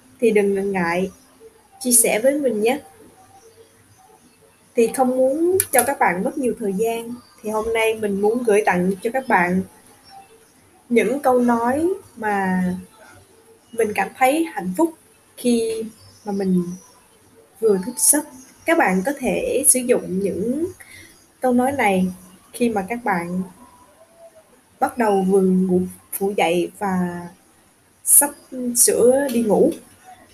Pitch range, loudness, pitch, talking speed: 195-270 Hz, -19 LUFS, 235 Hz, 135 wpm